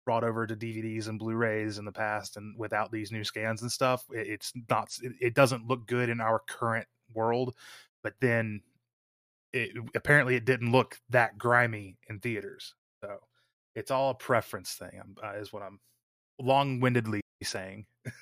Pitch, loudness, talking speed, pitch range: 115 Hz, -30 LUFS, 170 wpm, 110-125 Hz